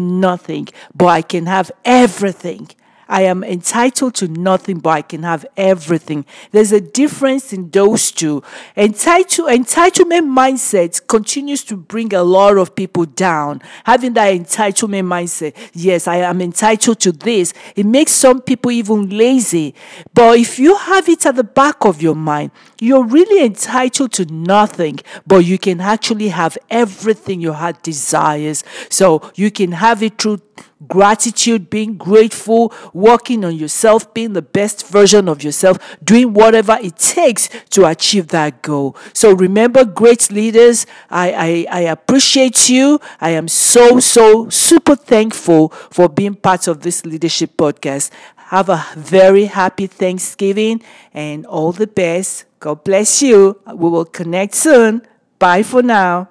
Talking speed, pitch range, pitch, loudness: 150 wpm, 175-235 Hz, 200 Hz, -12 LUFS